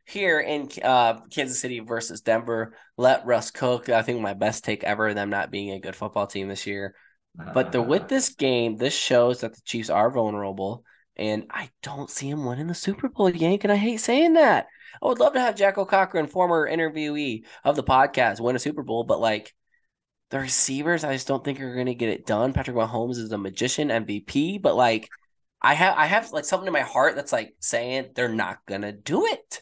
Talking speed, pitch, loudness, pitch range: 220 wpm, 130 Hz, -24 LUFS, 115-165 Hz